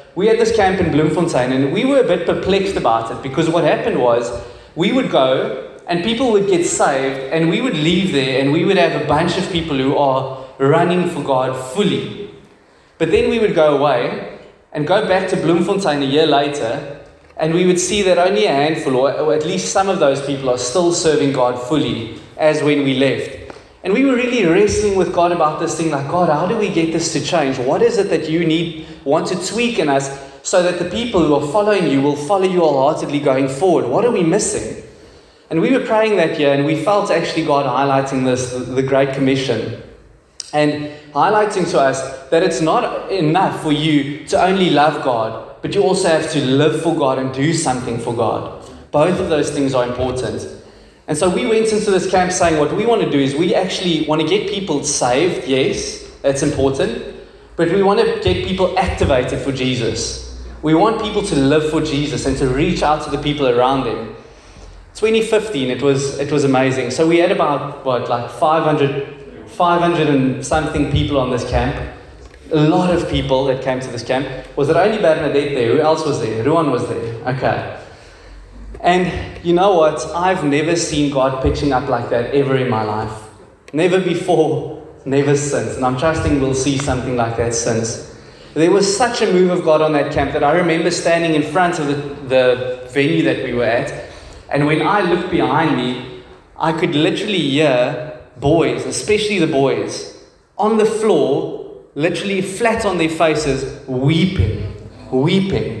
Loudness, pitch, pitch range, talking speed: -16 LUFS, 155 Hz, 135-180 Hz, 200 wpm